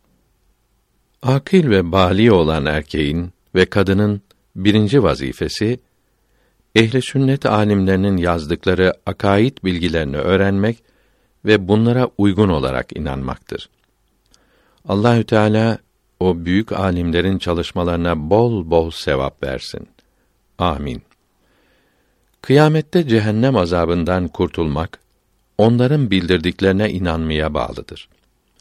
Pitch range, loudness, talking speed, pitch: 85-110 Hz, -17 LUFS, 85 wpm, 95 Hz